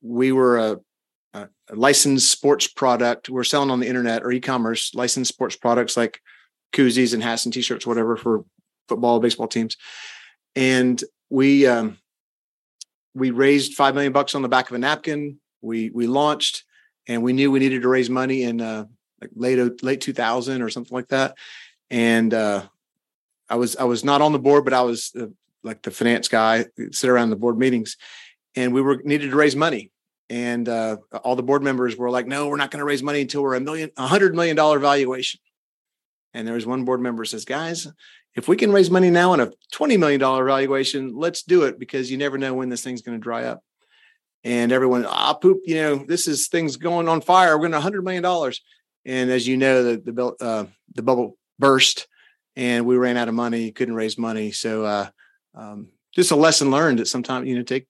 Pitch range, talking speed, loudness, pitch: 120-140 Hz, 210 wpm, -20 LUFS, 130 Hz